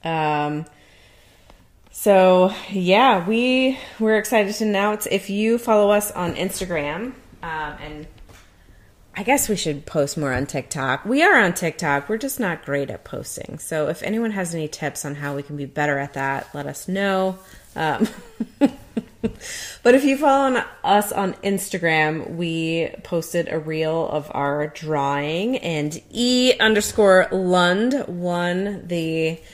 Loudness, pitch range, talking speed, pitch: -21 LUFS, 150-215 Hz, 150 wpm, 175 Hz